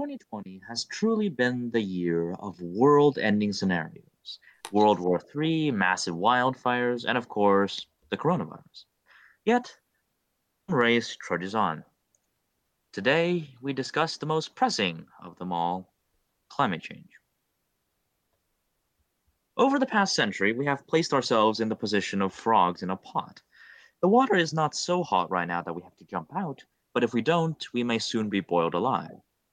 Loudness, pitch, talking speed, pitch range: -26 LUFS, 120 Hz, 150 wpm, 100-160 Hz